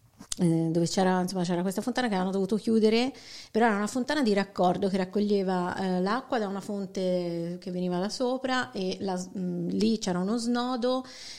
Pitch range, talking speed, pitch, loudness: 180-230 Hz, 180 wpm, 195 Hz, -28 LUFS